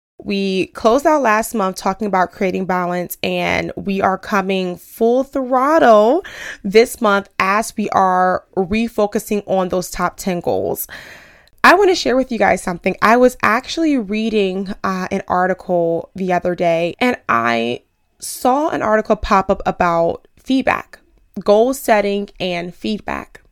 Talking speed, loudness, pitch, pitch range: 145 wpm, -16 LUFS, 195 Hz, 185-225 Hz